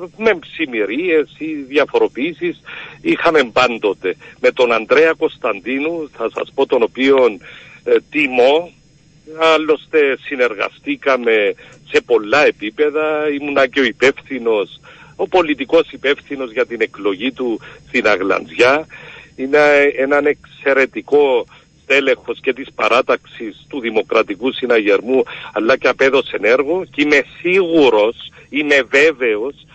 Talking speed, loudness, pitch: 110 wpm, -15 LUFS, 285 Hz